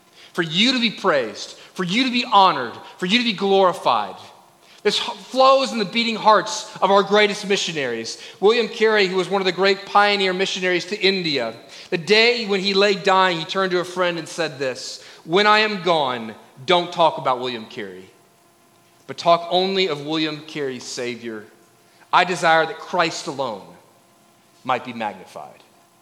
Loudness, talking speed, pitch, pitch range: -19 LUFS, 175 wpm, 185 Hz, 160-205 Hz